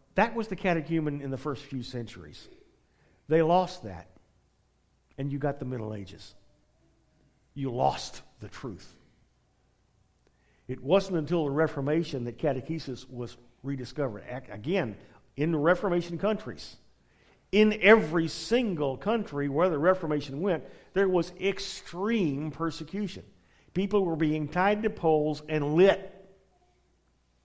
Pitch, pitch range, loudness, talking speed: 155 Hz, 130-185 Hz, -28 LUFS, 120 wpm